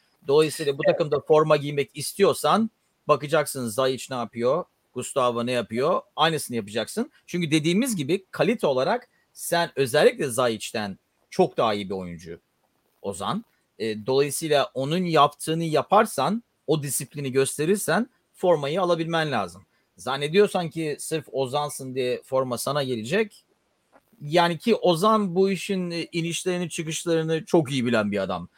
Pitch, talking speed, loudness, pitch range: 150 Hz, 125 wpm, -24 LUFS, 130-175 Hz